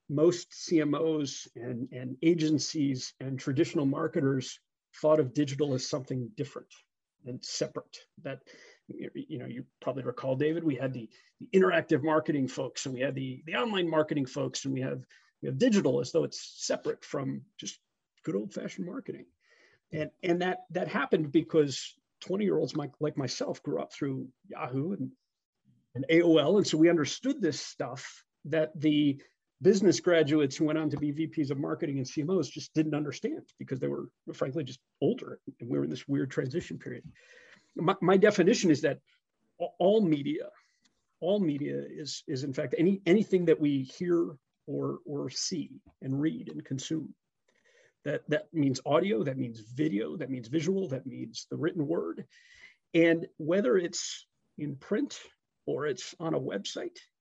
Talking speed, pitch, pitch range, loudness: 165 wpm, 155 Hz, 135-175 Hz, -30 LUFS